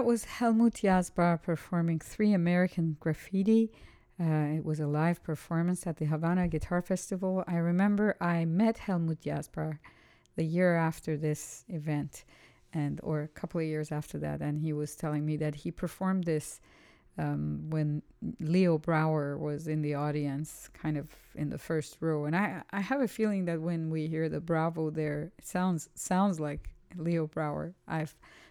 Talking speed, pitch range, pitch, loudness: 170 wpm, 150-180 Hz, 160 Hz, -32 LUFS